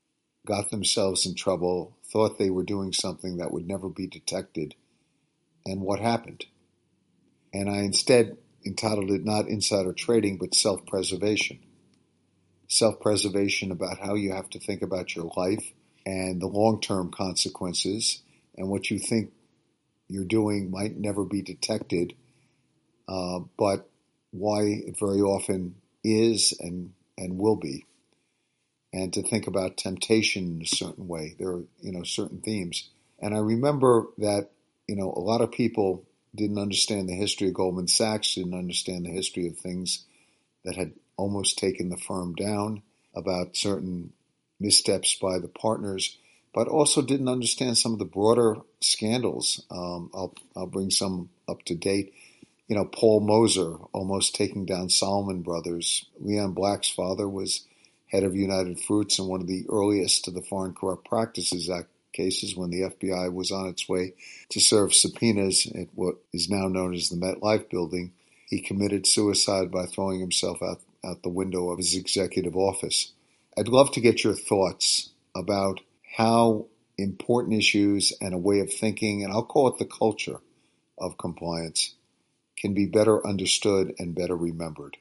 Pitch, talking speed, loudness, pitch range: 95 Hz, 160 wpm, -26 LUFS, 90-105 Hz